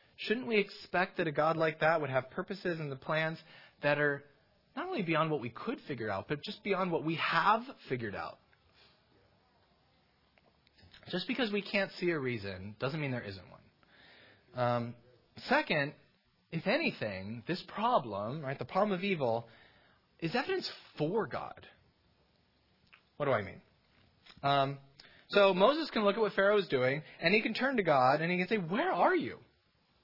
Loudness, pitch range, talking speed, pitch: -33 LUFS, 135-200 Hz, 170 wpm, 165 Hz